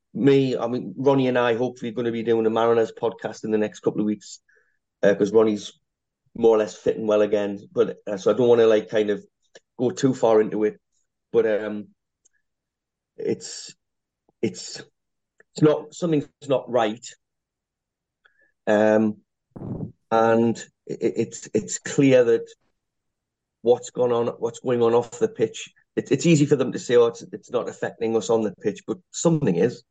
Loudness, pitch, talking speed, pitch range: -22 LUFS, 120 Hz, 180 wpm, 110-160 Hz